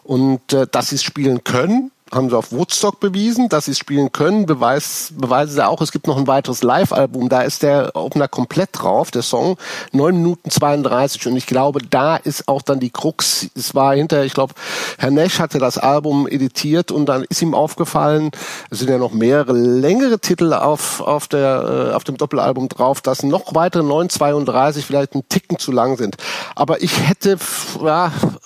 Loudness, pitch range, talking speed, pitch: -16 LUFS, 130-165 Hz, 190 wpm, 145 Hz